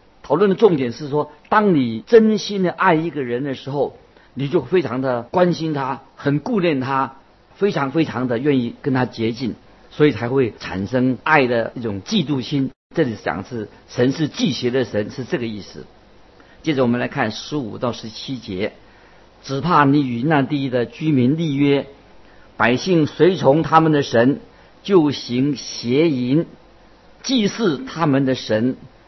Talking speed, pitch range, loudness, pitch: 230 characters per minute, 120-155 Hz, -19 LUFS, 135 Hz